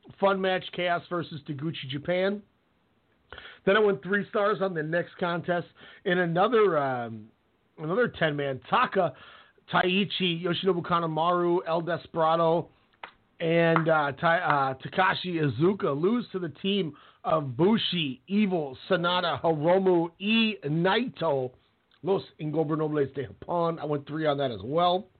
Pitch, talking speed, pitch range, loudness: 170 Hz, 130 wpm, 155-185 Hz, -27 LUFS